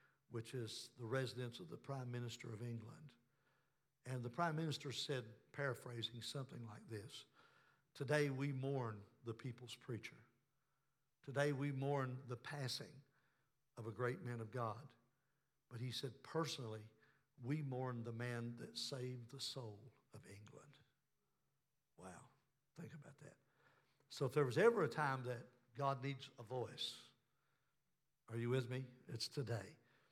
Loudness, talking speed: -45 LUFS, 145 wpm